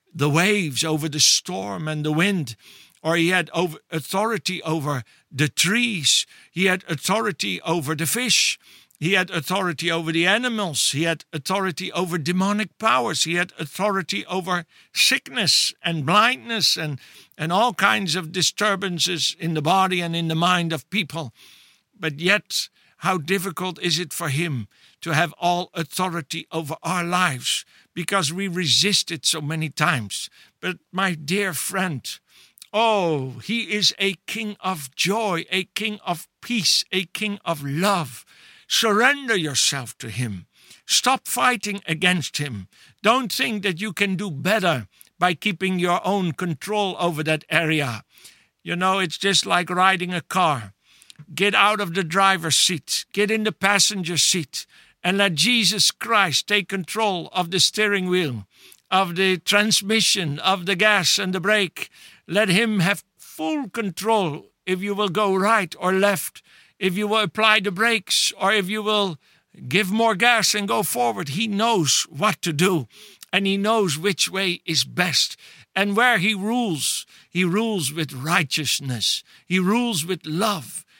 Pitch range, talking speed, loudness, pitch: 160-205 Hz, 155 wpm, -21 LUFS, 185 Hz